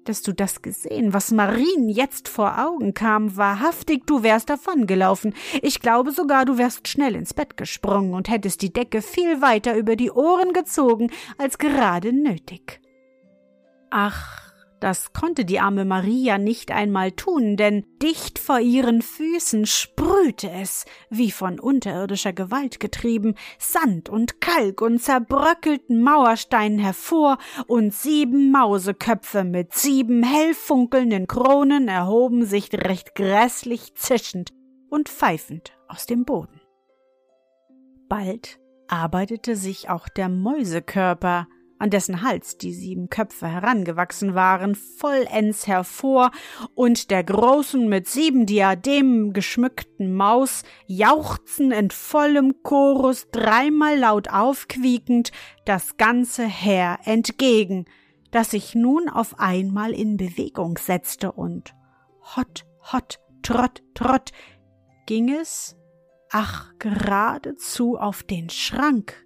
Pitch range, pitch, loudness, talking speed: 195-260 Hz, 225 Hz, -21 LUFS, 120 wpm